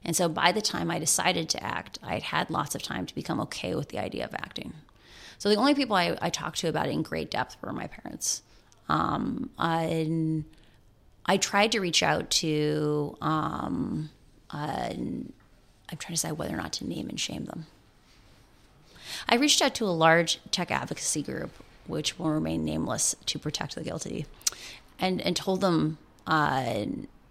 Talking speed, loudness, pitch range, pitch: 180 wpm, -28 LUFS, 155-195 Hz, 165 Hz